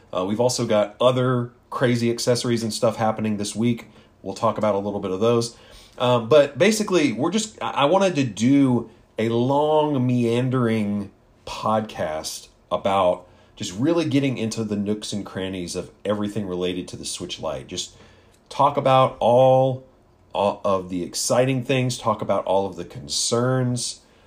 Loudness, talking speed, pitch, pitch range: -22 LUFS, 160 wpm, 115 Hz, 100-125 Hz